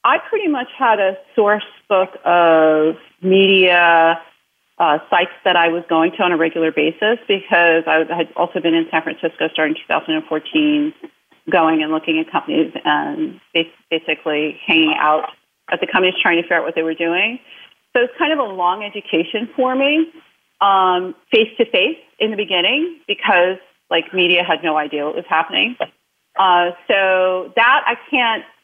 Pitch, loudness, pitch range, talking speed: 180 Hz, -16 LUFS, 165-220 Hz, 170 wpm